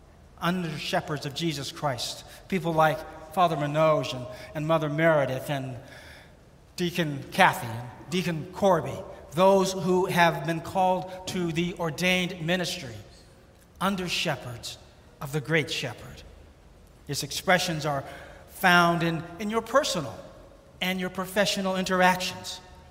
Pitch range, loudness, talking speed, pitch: 140-180 Hz, -26 LUFS, 120 wpm, 165 Hz